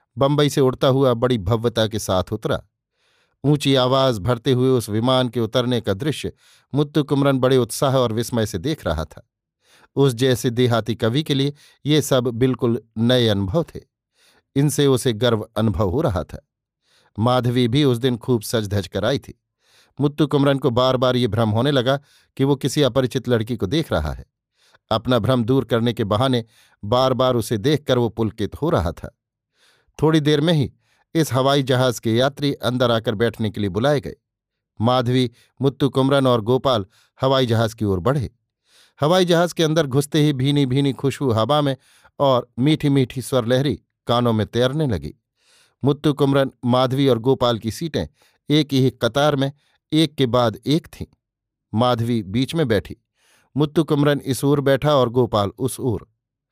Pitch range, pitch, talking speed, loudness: 115-140 Hz, 130 Hz, 175 wpm, -20 LUFS